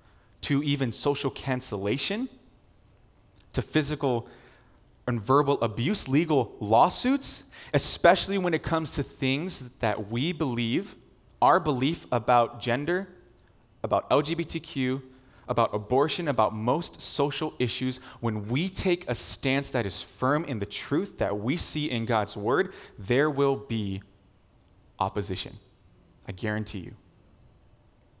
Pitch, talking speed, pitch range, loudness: 125 Hz, 120 wpm, 110-140 Hz, -26 LUFS